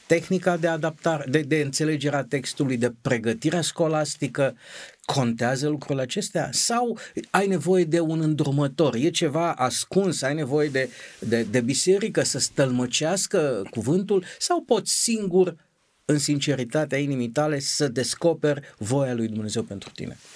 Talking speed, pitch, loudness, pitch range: 135 wpm, 150 Hz, -24 LUFS, 135-170 Hz